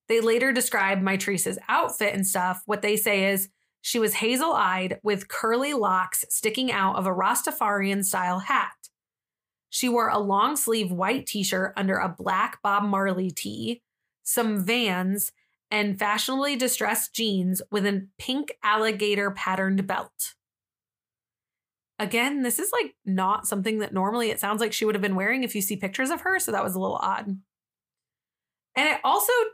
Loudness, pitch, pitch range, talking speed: -25 LUFS, 205 Hz, 190-230 Hz, 155 wpm